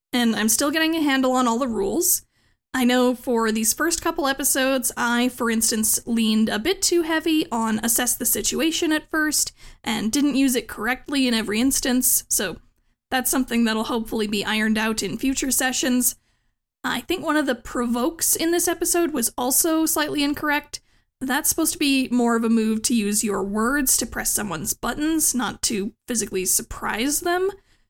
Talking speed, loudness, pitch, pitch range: 180 wpm, -21 LUFS, 255 Hz, 230-305 Hz